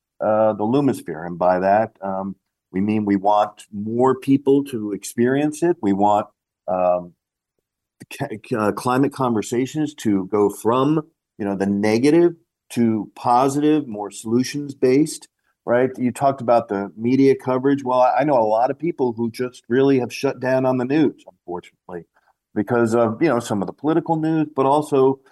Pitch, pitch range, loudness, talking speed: 120 Hz, 105-135 Hz, -20 LUFS, 165 wpm